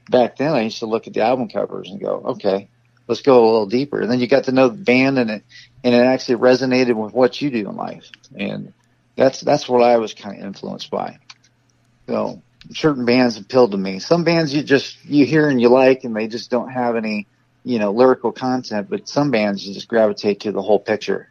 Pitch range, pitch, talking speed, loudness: 115-130 Hz, 125 Hz, 240 wpm, -18 LUFS